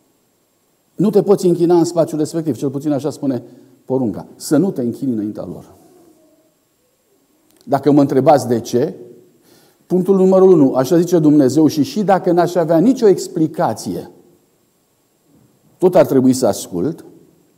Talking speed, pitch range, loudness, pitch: 140 wpm, 145-190 Hz, -15 LUFS, 170 Hz